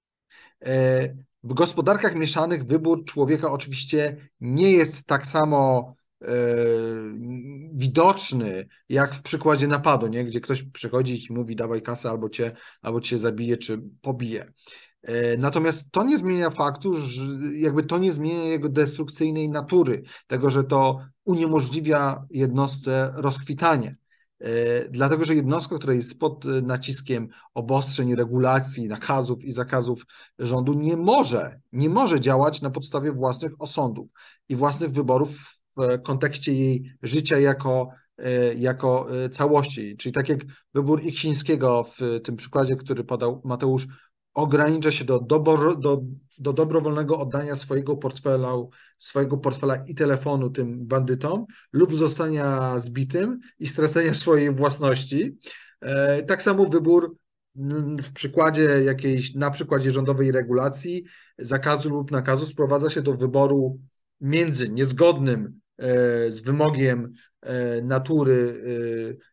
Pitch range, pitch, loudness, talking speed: 125-155 Hz, 140 Hz, -23 LUFS, 120 wpm